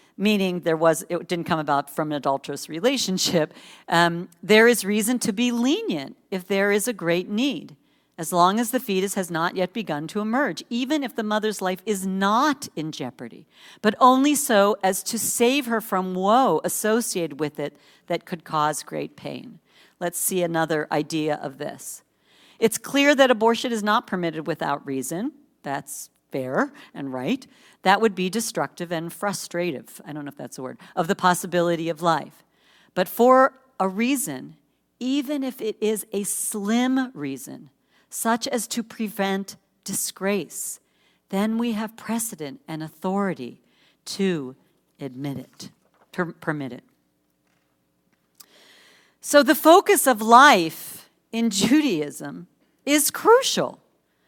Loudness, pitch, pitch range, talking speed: -22 LUFS, 195 Hz, 160-235 Hz, 150 wpm